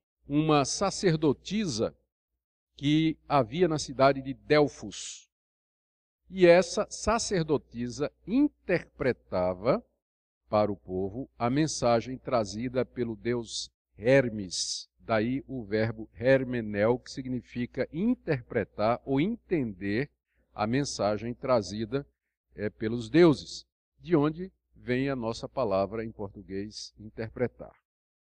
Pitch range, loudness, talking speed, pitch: 105-145 Hz, -29 LUFS, 95 wpm, 120 Hz